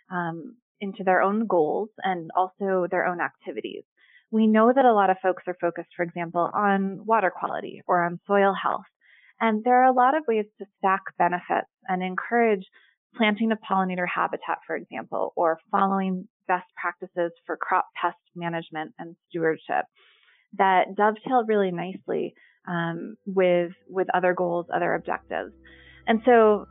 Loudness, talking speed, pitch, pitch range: -25 LUFS, 155 wpm, 190 Hz, 175-215 Hz